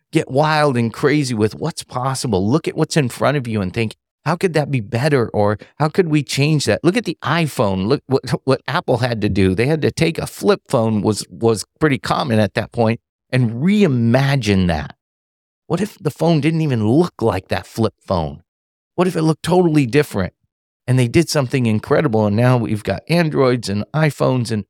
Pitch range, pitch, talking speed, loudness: 110-155 Hz, 130 Hz, 205 wpm, -18 LUFS